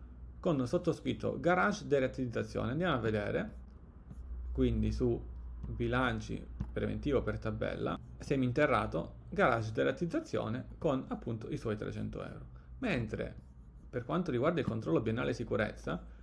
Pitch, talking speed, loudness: 115 Hz, 115 wpm, -35 LUFS